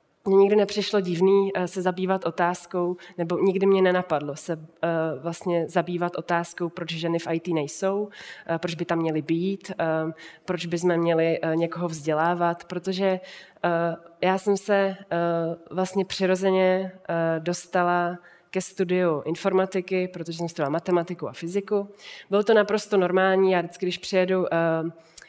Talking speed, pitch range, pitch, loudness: 130 wpm, 170-190 Hz, 175 Hz, -25 LUFS